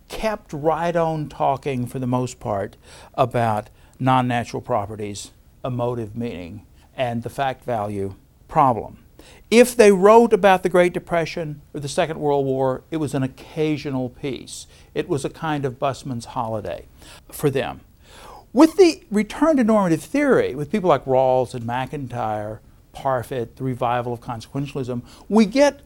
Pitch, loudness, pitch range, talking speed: 135 Hz, -21 LUFS, 120-165 Hz, 150 wpm